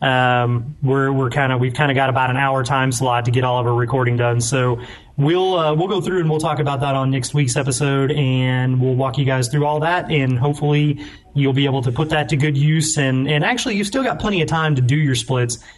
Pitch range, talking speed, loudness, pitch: 130-150 Hz, 260 wpm, -18 LUFS, 135 Hz